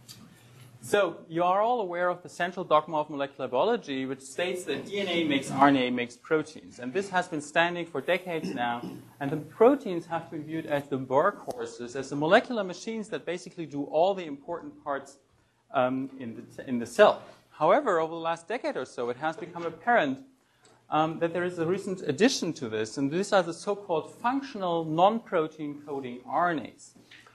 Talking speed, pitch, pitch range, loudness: 185 wpm, 160 Hz, 140-180 Hz, -28 LUFS